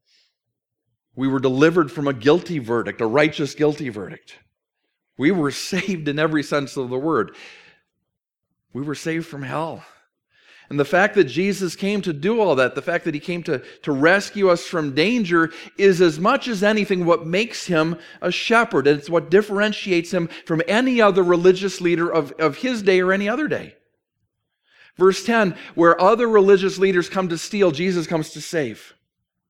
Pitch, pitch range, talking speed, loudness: 170 Hz, 150-195 Hz, 175 wpm, -19 LUFS